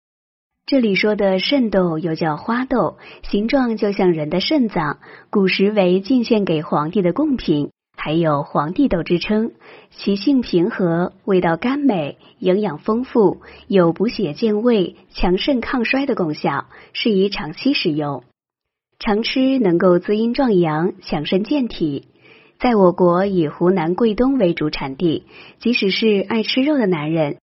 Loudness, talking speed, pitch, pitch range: -18 LUFS, 215 characters per minute, 195 Hz, 175-235 Hz